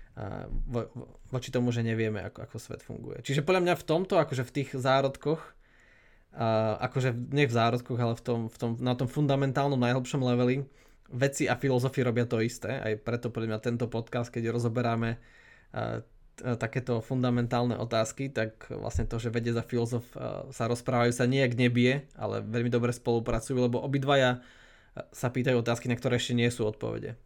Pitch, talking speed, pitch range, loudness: 120 Hz, 170 wpm, 115-130 Hz, -29 LUFS